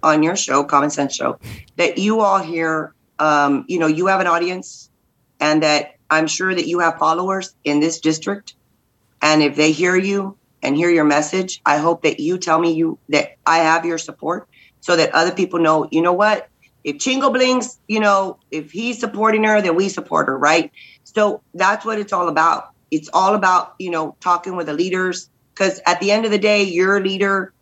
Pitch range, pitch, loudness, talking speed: 155-195 Hz, 175 Hz, -17 LUFS, 210 wpm